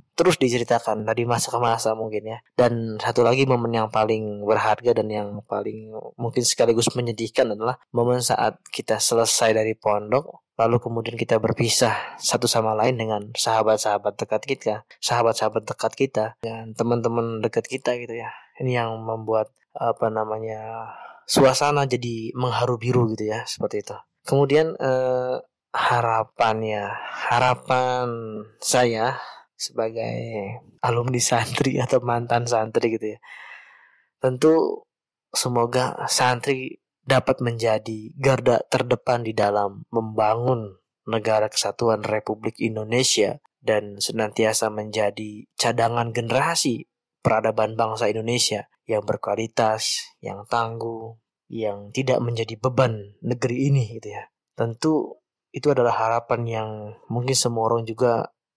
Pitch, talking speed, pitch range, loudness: 115 Hz, 120 wpm, 110-125 Hz, -23 LUFS